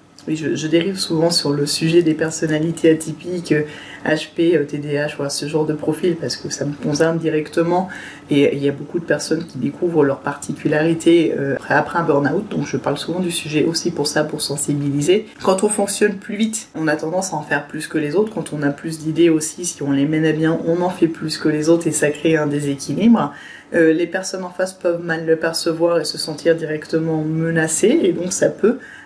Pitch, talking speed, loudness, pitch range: 160 Hz, 215 wpm, -19 LUFS, 150-170 Hz